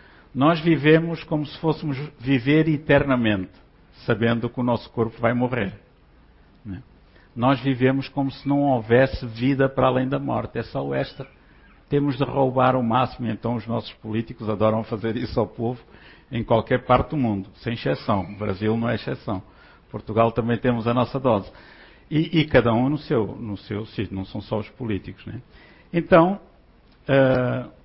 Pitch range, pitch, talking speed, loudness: 110-135 Hz, 120 Hz, 170 wpm, -23 LUFS